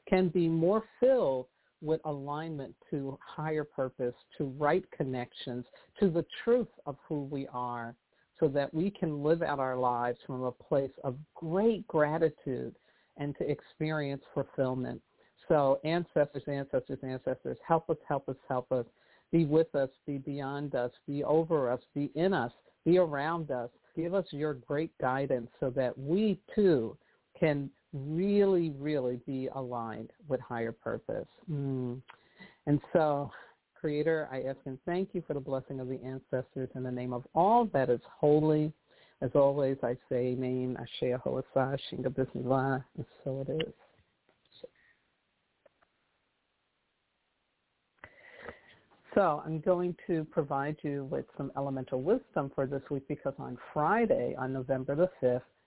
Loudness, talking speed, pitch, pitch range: -32 LUFS, 145 wpm, 140 Hz, 130-160 Hz